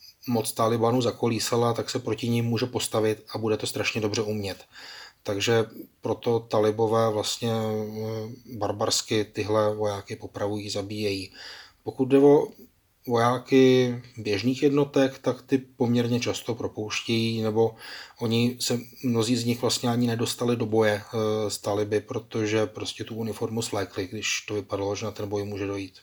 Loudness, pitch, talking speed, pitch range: -26 LUFS, 115 Hz, 145 wpm, 105-120 Hz